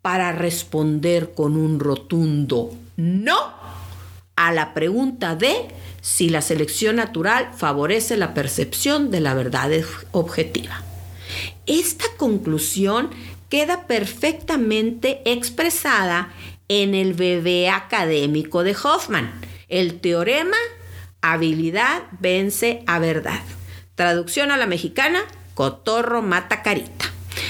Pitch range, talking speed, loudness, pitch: 135-220 Hz, 100 wpm, -20 LUFS, 170 Hz